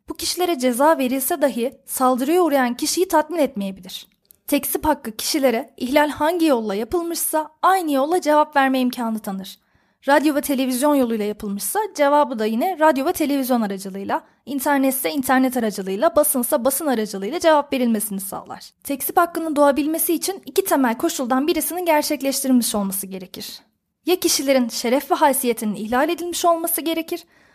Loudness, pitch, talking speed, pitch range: -20 LUFS, 280 Hz, 140 wpm, 240-320 Hz